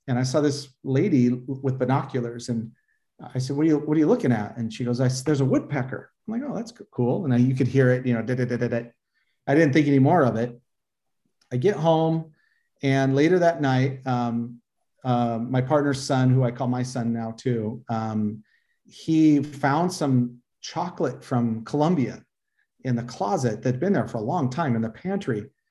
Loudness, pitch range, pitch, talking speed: -24 LUFS, 120-145 Hz, 130 Hz, 210 wpm